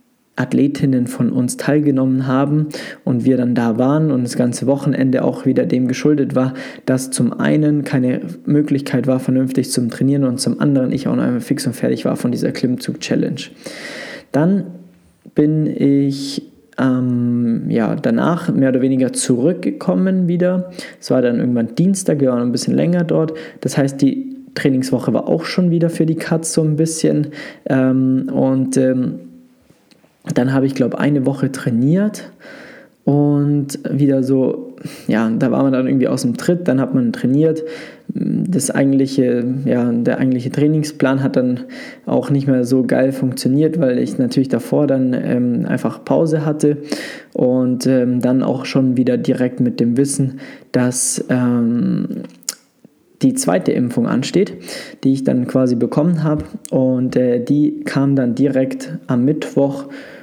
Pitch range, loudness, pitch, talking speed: 130-155 Hz, -17 LUFS, 135 Hz, 160 wpm